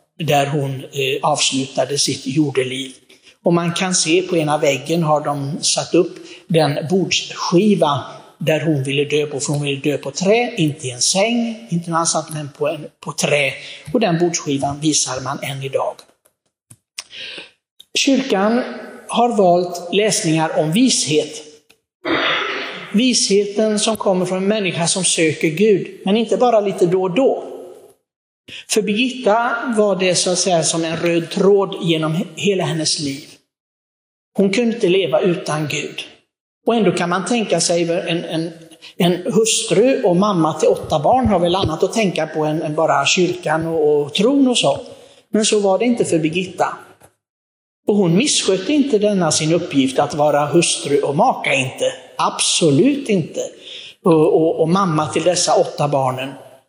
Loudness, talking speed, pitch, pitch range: -17 LUFS, 160 wpm, 170 Hz, 150-205 Hz